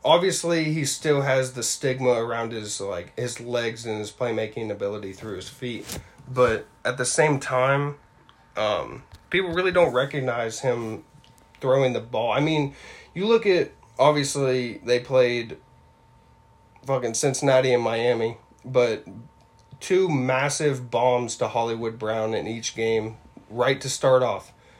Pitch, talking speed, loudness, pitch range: 125 Hz, 140 wpm, -24 LUFS, 115-140 Hz